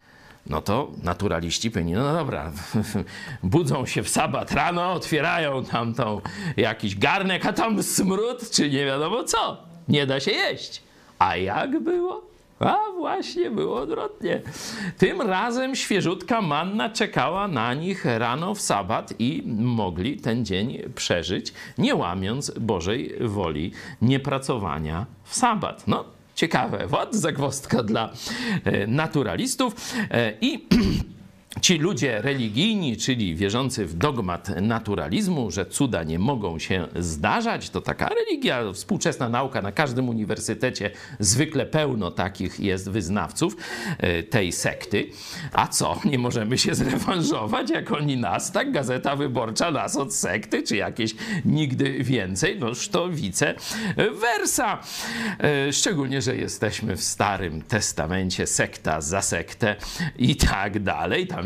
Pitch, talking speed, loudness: 135 Hz, 125 wpm, -24 LUFS